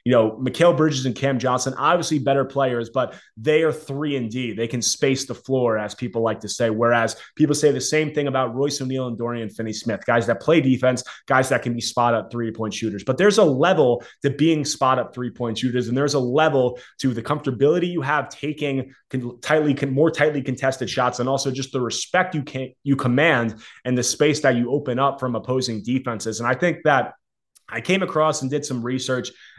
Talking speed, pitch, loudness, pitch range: 220 wpm, 130 Hz, -21 LUFS, 120-145 Hz